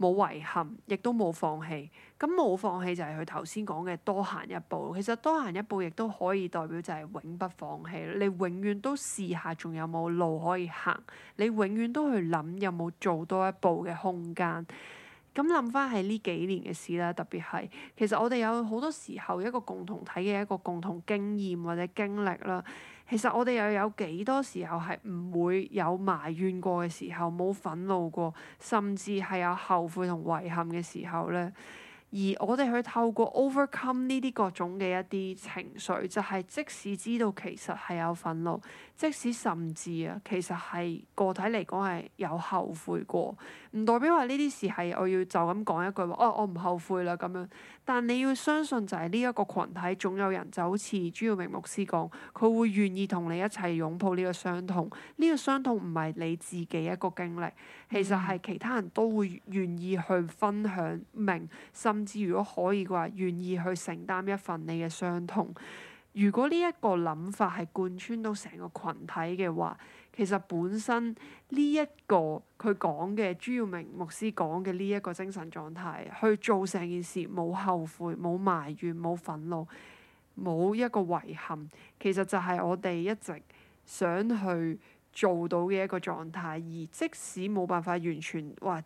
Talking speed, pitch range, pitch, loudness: 265 characters per minute, 175-210 Hz, 185 Hz, -32 LUFS